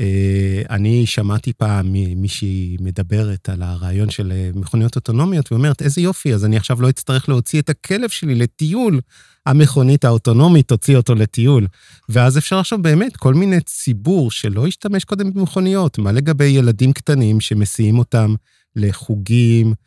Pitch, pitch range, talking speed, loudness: 125 Hz, 105-150 Hz, 140 wpm, -16 LUFS